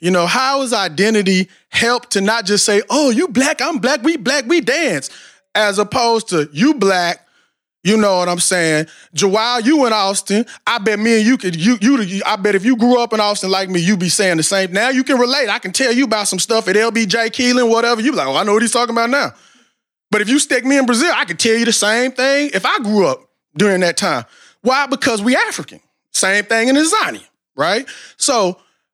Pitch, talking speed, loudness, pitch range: 225 Hz, 235 wpm, -15 LUFS, 200-260 Hz